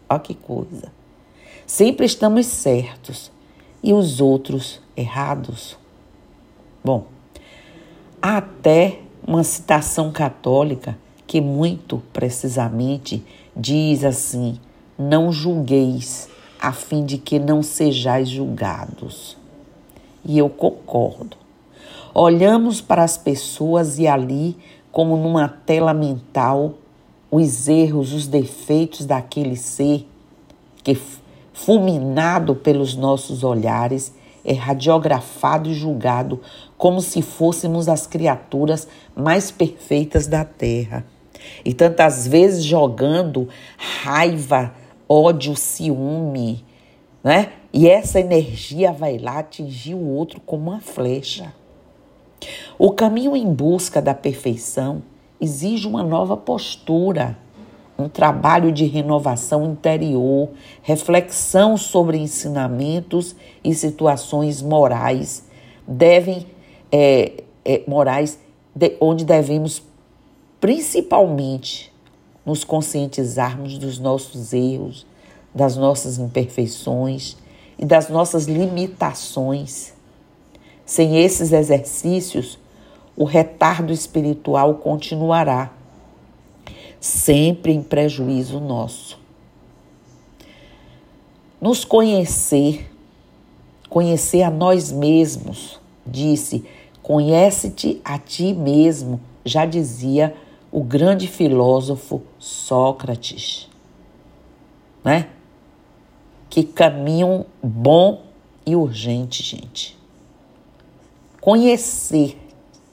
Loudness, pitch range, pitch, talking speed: -18 LUFS, 135-165 Hz, 150 Hz, 85 wpm